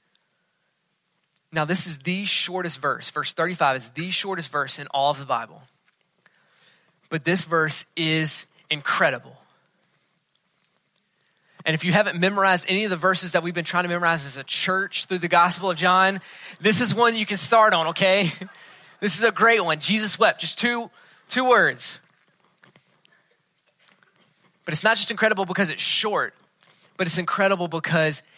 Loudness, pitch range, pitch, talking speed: -21 LUFS, 165-200 Hz, 180 Hz, 160 wpm